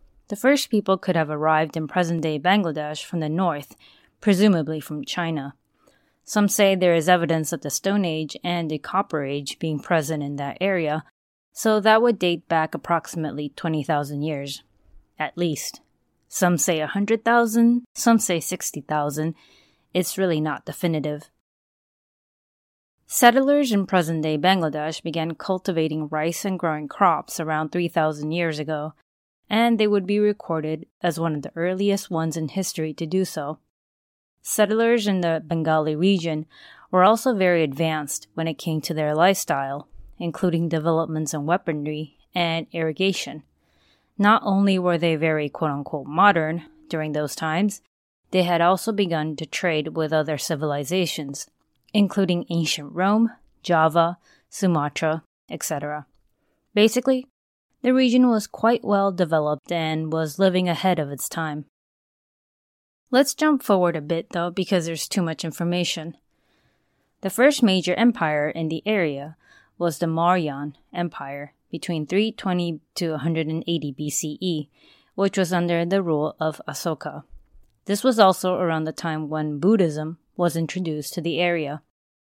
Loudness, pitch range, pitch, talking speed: -23 LUFS, 155-190 Hz, 165 Hz, 145 wpm